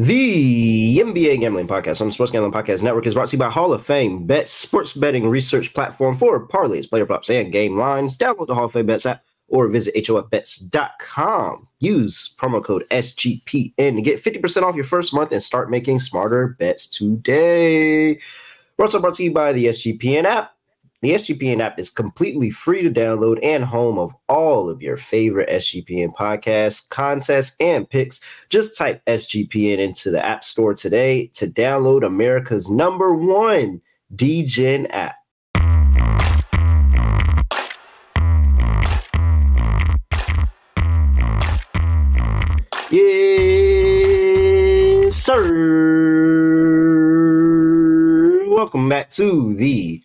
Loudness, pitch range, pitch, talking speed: -17 LUFS, 105-160 Hz, 125 Hz, 130 wpm